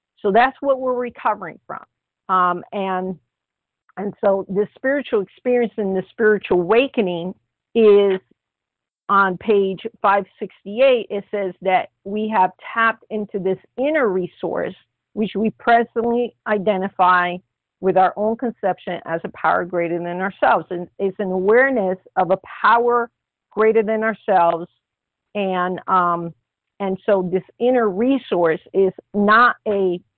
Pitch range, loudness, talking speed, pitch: 185-225 Hz, -19 LUFS, 130 wpm, 200 Hz